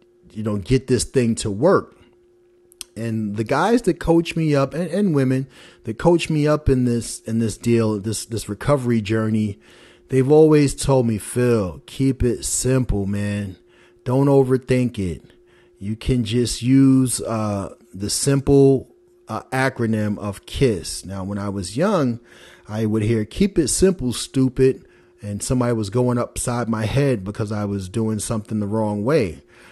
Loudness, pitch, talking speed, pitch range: -20 LUFS, 120 Hz, 160 wpm, 105-135 Hz